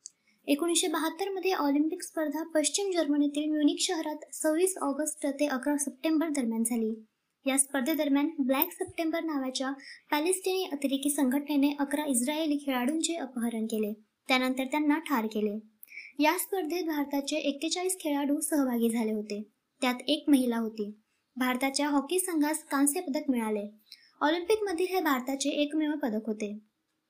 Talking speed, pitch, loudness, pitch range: 120 wpm, 290 Hz, -29 LUFS, 260-315 Hz